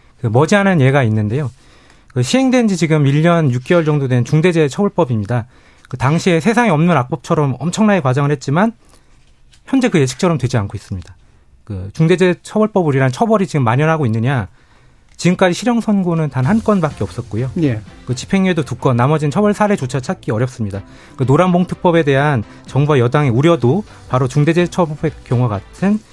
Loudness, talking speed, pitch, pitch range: -15 LUFS, 390 characters per minute, 150 Hz, 125-180 Hz